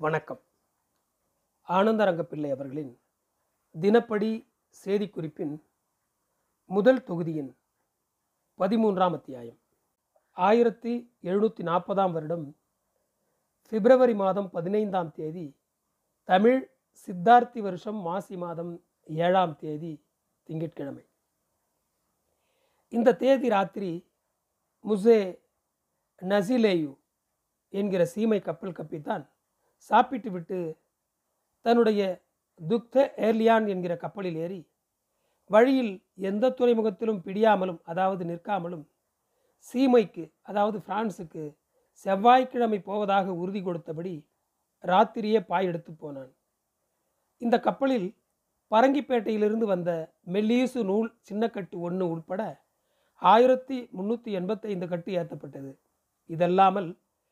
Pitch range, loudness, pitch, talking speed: 170-225 Hz, -26 LUFS, 195 Hz, 75 wpm